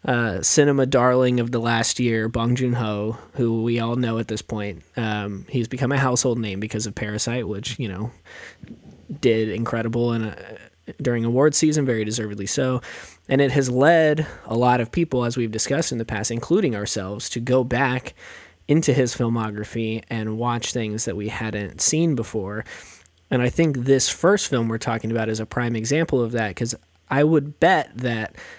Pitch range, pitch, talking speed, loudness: 110-130 Hz, 120 Hz, 185 wpm, -22 LUFS